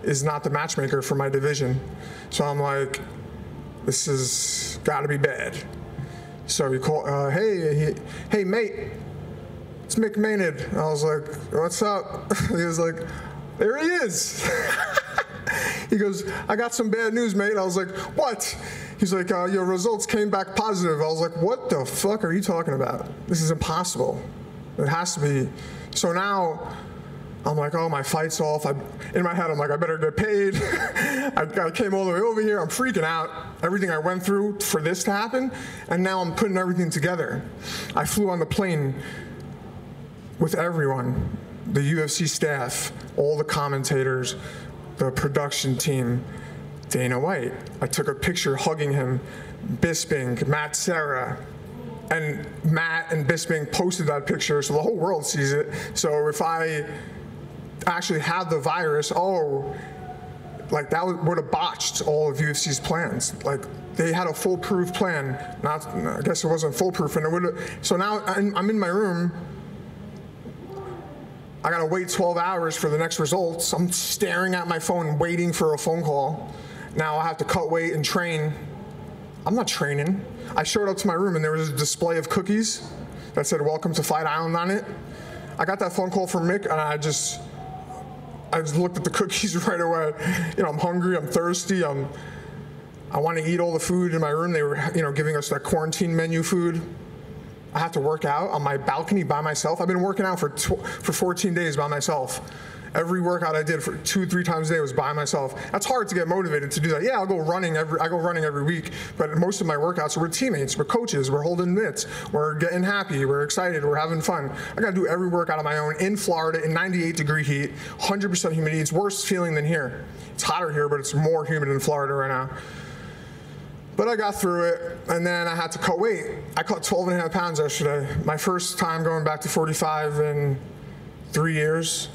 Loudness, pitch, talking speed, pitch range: -24 LUFS, 165 Hz, 195 wpm, 150-185 Hz